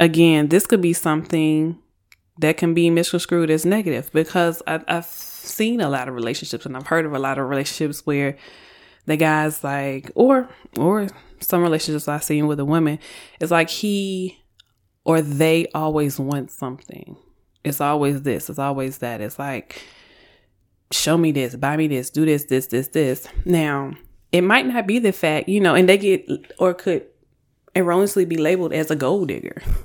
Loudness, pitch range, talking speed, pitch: -20 LUFS, 140-175 Hz, 175 wpm, 155 Hz